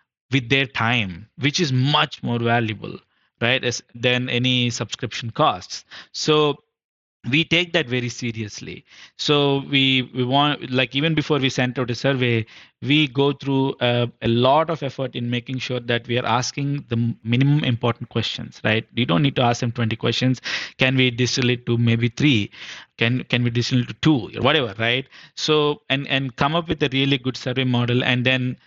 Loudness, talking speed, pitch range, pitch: -21 LUFS, 190 wpm, 120-140 Hz, 125 Hz